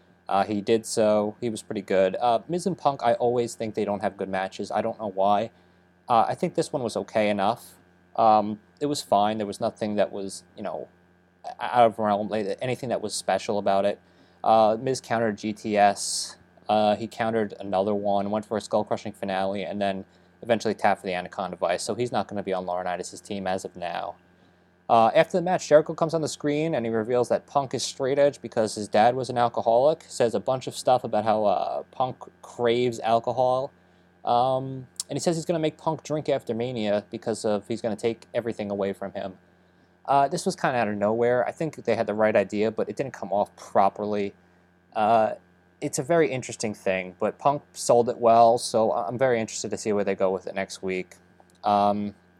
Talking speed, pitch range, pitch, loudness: 220 wpm, 95-120 Hz, 105 Hz, -25 LUFS